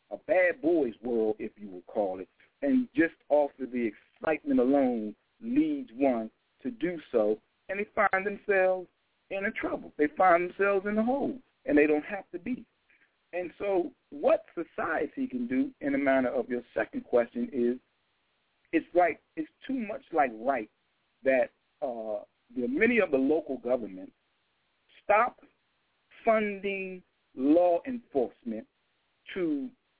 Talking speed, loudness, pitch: 150 wpm, -29 LUFS, 200 Hz